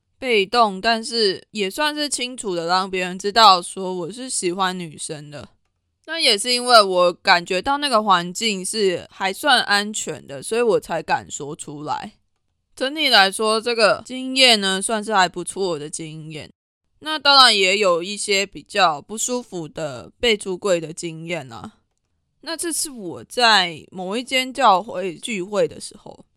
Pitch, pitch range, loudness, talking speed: 200 Hz, 180-245 Hz, -18 LUFS, 230 characters per minute